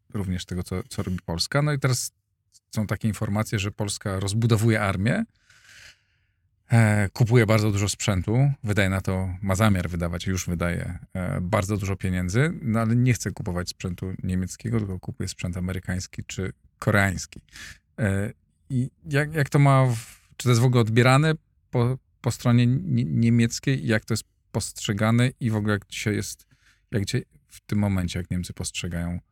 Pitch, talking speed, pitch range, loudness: 105 Hz, 165 wpm, 95-120 Hz, -25 LUFS